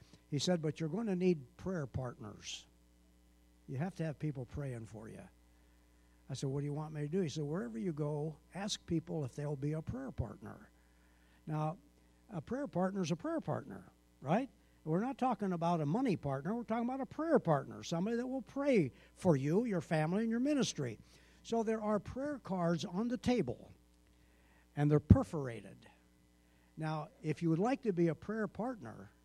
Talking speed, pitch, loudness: 190 wpm, 155 Hz, -37 LUFS